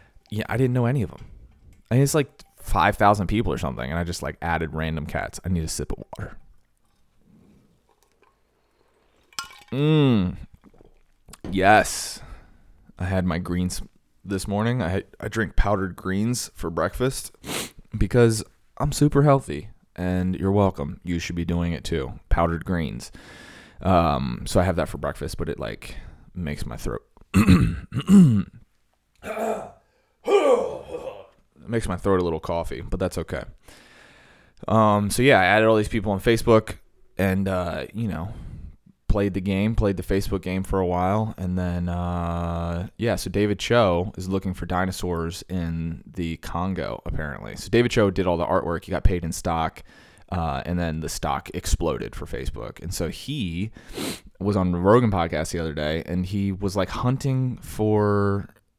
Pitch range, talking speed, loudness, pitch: 85-110 Hz, 165 wpm, -24 LUFS, 95 Hz